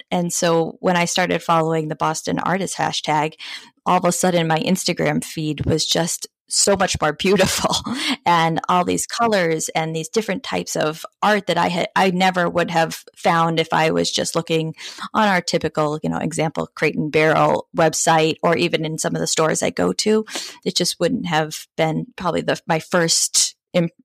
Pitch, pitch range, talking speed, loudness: 170 Hz, 160-185 Hz, 190 wpm, -19 LUFS